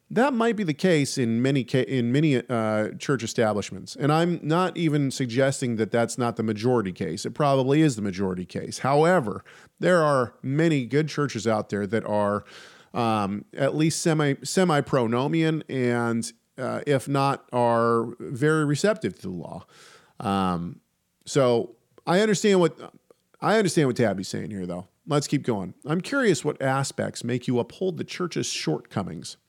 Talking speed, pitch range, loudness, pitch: 160 wpm, 115-155 Hz, -24 LUFS, 135 Hz